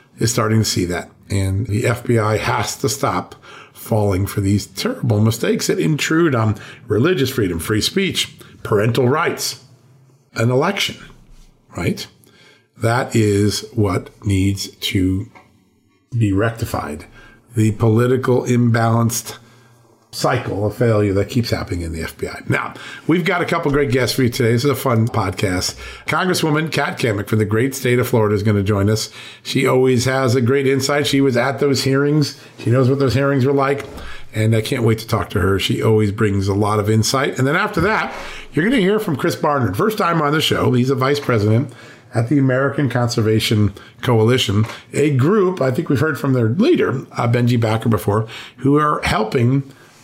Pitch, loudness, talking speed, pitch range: 120 Hz, -18 LUFS, 180 wpm, 110-135 Hz